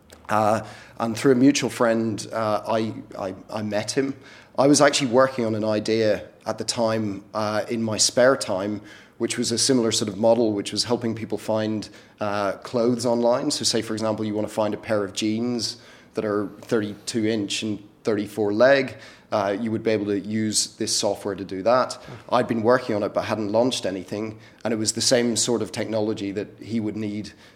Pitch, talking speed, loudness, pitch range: 110 Hz, 205 wpm, -23 LUFS, 105-115 Hz